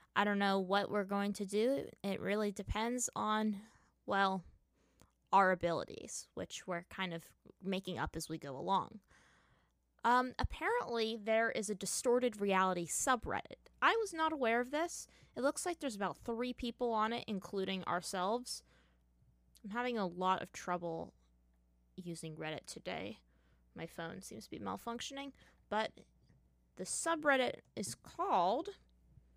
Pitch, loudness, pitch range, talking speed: 200 Hz, -37 LUFS, 175-235 Hz, 145 wpm